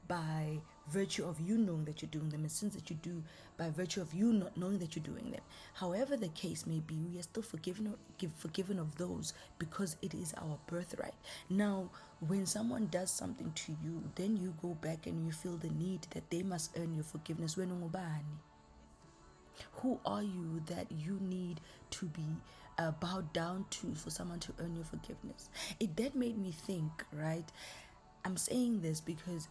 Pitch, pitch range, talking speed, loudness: 175 Hz, 160-190 Hz, 185 wpm, -40 LUFS